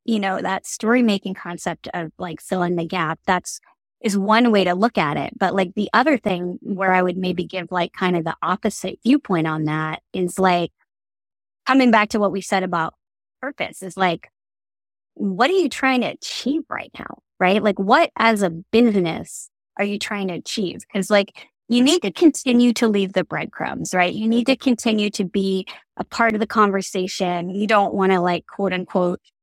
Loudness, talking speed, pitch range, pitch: -20 LUFS, 200 wpm, 180-225 Hz, 195 Hz